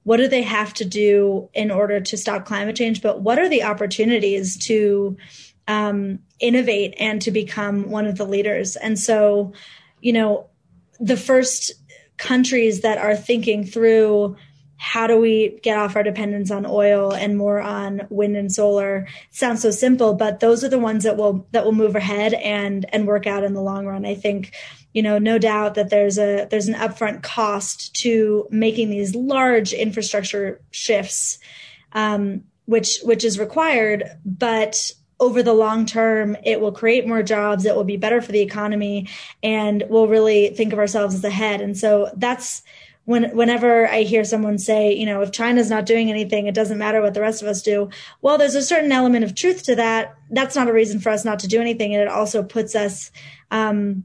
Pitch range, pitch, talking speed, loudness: 205-225 Hz, 215 Hz, 195 wpm, -19 LUFS